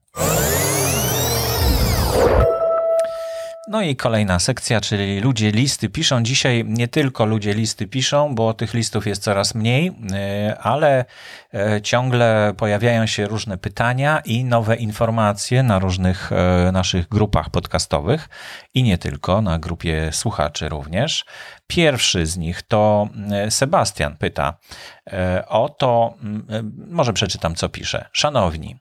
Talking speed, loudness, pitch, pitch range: 110 wpm, -19 LUFS, 110 Hz, 95-125 Hz